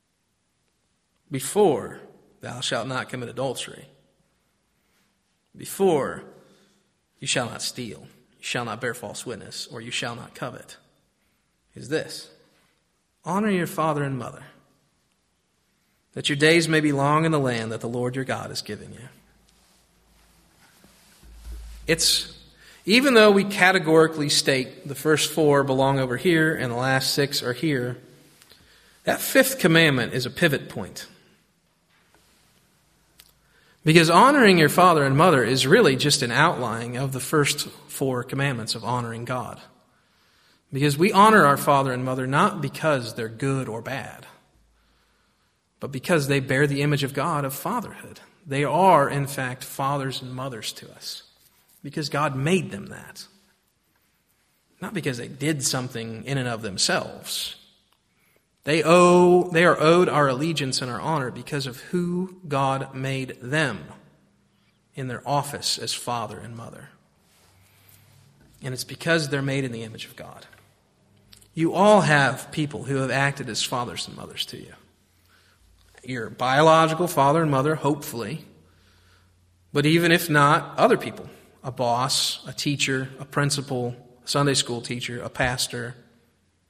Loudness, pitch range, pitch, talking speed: -22 LUFS, 120-155 Hz, 135 Hz, 145 wpm